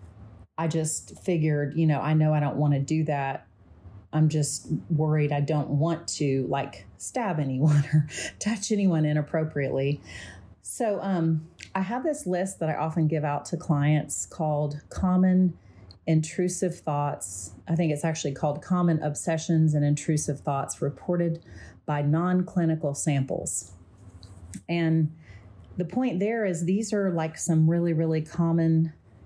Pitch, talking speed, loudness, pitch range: 155 Hz, 145 wpm, -26 LUFS, 140-170 Hz